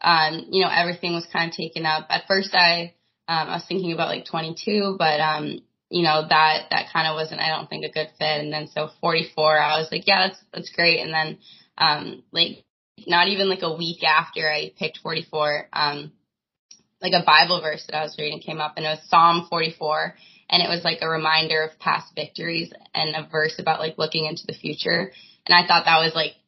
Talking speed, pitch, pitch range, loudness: 220 wpm, 160 Hz, 155-170 Hz, -21 LUFS